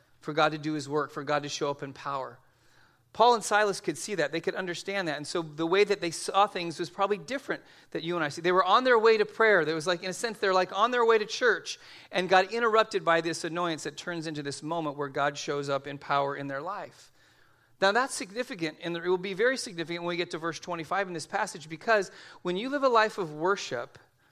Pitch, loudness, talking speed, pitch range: 175 Hz, -28 LUFS, 260 wpm, 155-205 Hz